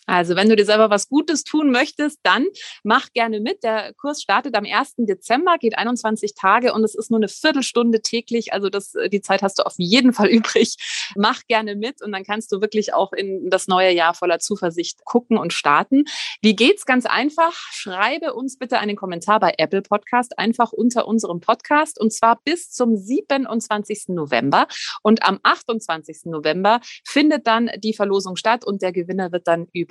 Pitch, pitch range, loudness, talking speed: 220 Hz, 195-245 Hz, -19 LUFS, 190 wpm